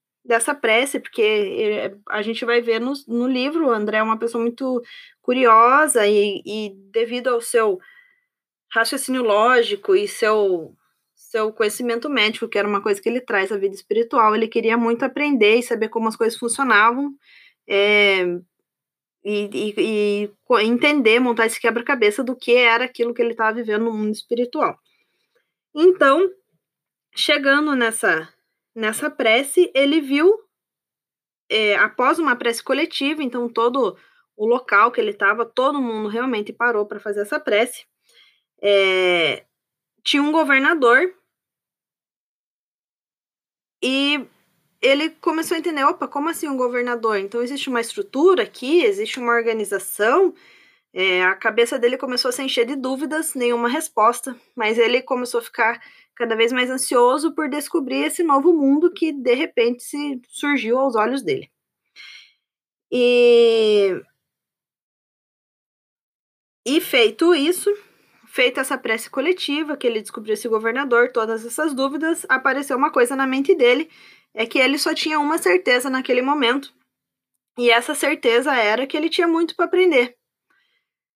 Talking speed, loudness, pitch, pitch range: 140 wpm, -19 LUFS, 255 Hz, 230-315 Hz